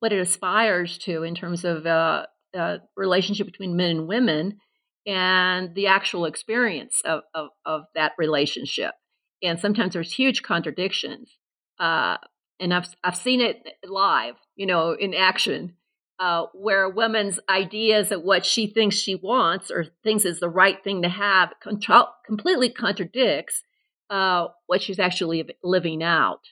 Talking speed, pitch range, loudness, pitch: 150 wpm, 175-205 Hz, -22 LUFS, 185 Hz